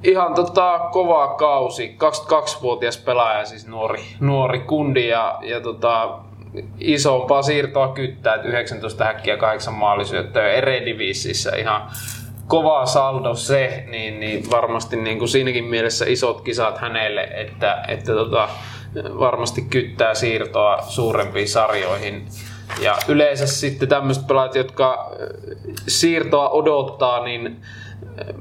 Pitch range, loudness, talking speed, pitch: 110-140 Hz, -19 LUFS, 115 wpm, 120 Hz